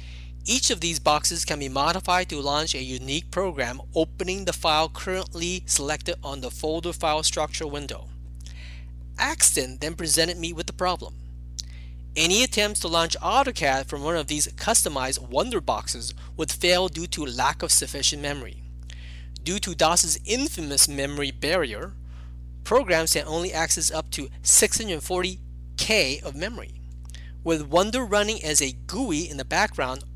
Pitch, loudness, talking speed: 150 Hz, -23 LUFS, 150 wpm